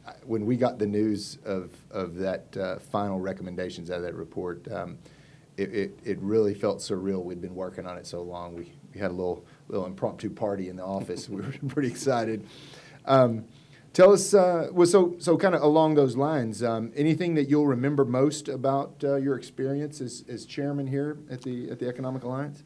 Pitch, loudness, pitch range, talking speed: 125 Hz, -27 LUFS, 100-145 Hz, 200 wpm